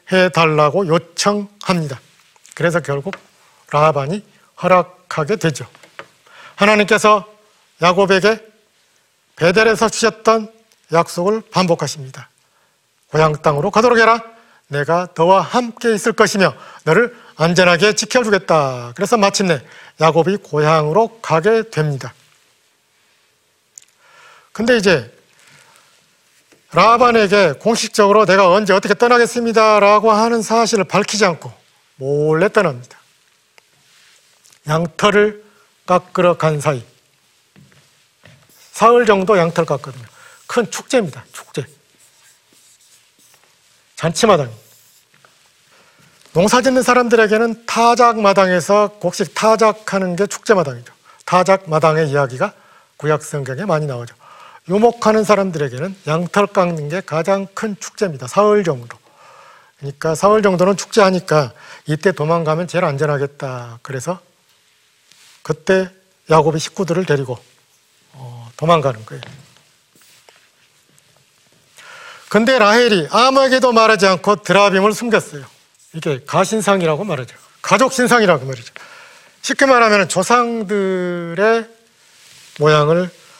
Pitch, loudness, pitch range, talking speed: 190 Hz, -15 LUFS, 155-215 Hz, 255 characters per minute